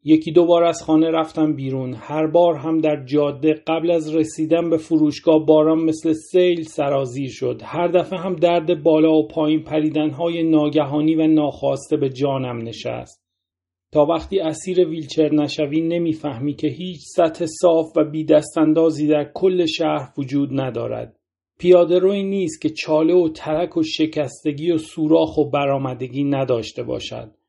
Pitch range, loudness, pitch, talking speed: 150-165 Hz, -19 LUFS, 155 Hz, 155 wpm